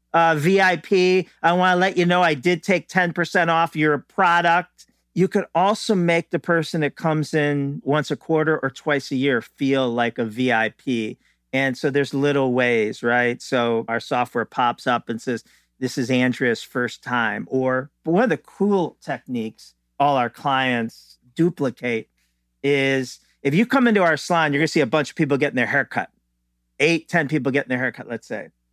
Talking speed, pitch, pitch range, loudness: 185 wpm, 140 Hz, 125-170 Hz, -21 LUFS